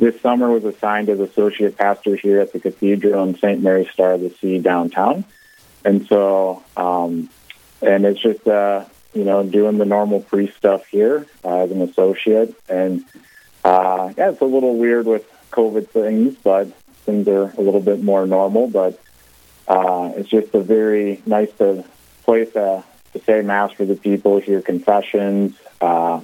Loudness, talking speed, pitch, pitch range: -17 LUFS, 170 wpm, 100 Hz, 95-105 Hz